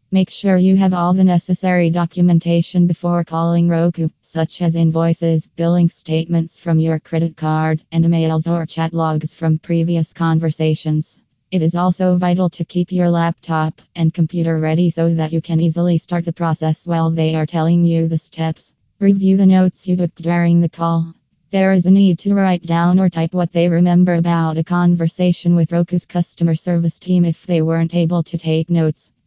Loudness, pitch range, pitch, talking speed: -16 LUFS, 160-175 Hz, 170 Hz, 180 wpm